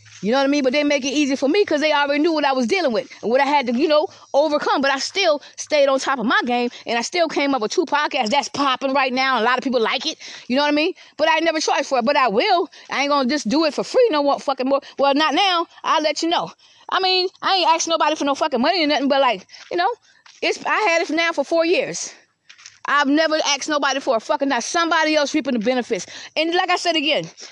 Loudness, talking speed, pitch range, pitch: -19 LUFS, 290 wpm, 275-325 Hz, 290 Hz